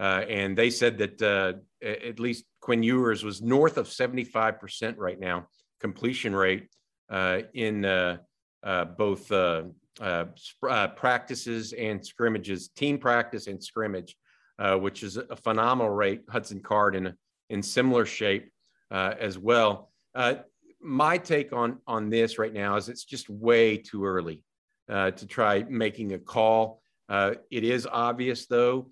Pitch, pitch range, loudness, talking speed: 110 Hz, 100-120 Hz, -27 LUFS, 150 wpm